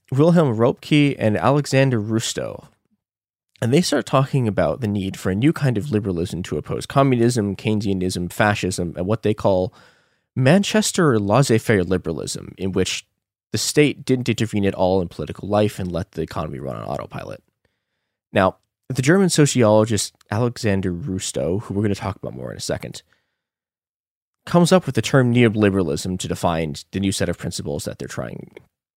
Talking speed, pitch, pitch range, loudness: 165 wpm, 105 Hz, 95-130 Hz, -20 LUFS